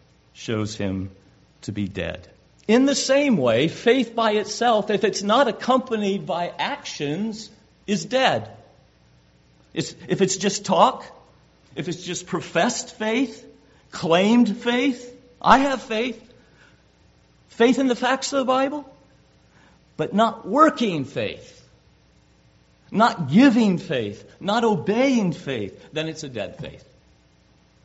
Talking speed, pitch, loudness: 125 wpm, 200 Hz, -22 LUFS